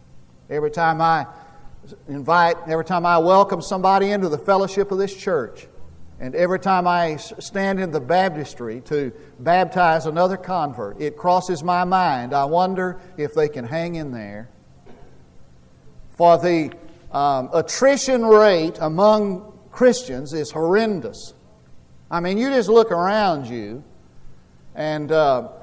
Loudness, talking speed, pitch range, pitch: -19 LUFS, 135 wpm, 140-185 Hz, 165 Hz